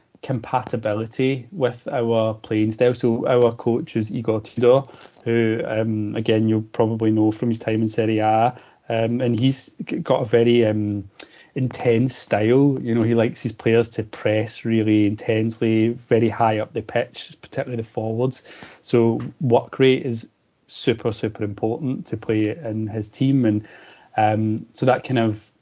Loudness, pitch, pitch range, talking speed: -21 LUFS, 115 Hz, 110-125 Hz, 160 wpm